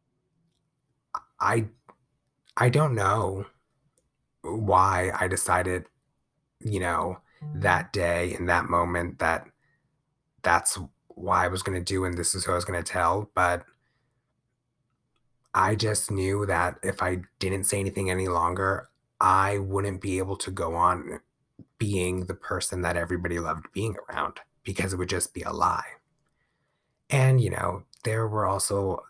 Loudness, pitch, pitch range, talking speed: -26 LUFS, 95 Hz, 90-115 Hz, 140 wpm